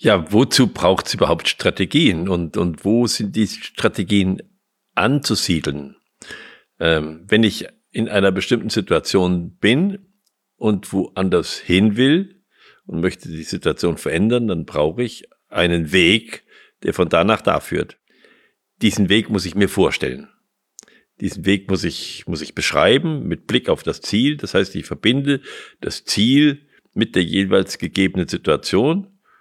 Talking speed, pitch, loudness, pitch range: 145 wpm, 105 Hz, -18 LUFS, 95-130 Hz